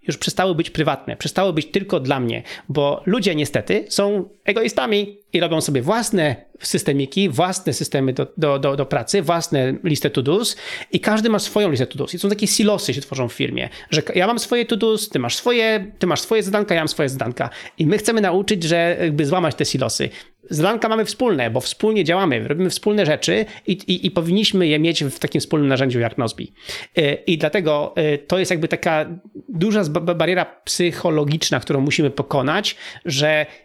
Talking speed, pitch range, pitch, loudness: 185 wpm, 145-200 Hz, 170 Hz, -19 LUFS